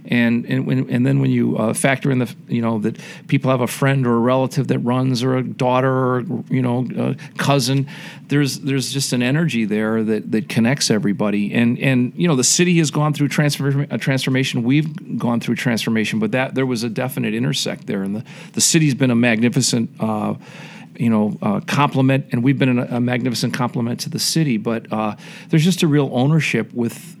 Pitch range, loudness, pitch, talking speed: 120-145 Hz, -18 LUFS, 130 Hz, 210 wpm